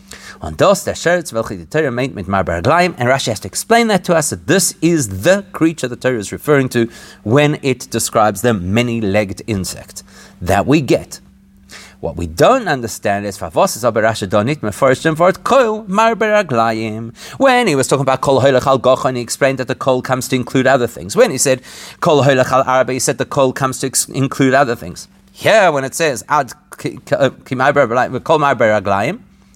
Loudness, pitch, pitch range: -15 LUFS, 130 Hz, 110-145 Hz